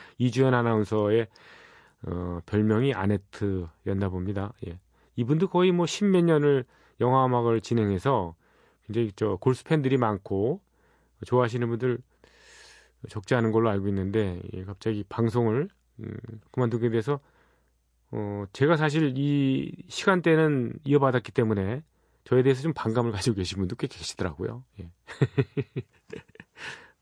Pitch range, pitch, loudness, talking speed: 100-135 Hz, 115 Hz, -26 LUFS, 280 characters per minute